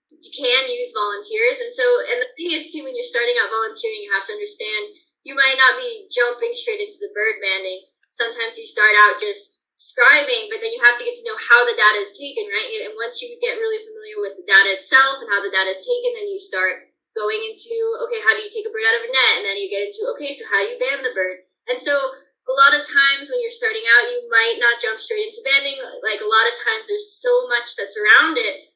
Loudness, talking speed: -17 LUFS, 255 wpm